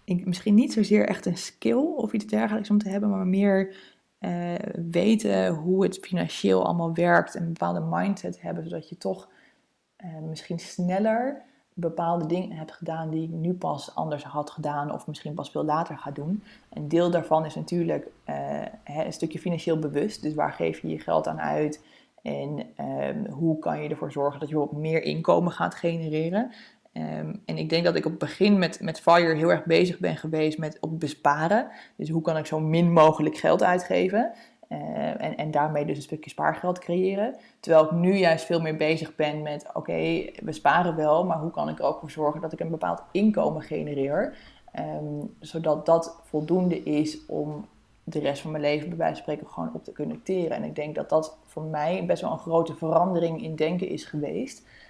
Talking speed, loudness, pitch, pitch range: 200 wpm, -26 LUFS, 160 Hz, 150-180 Hz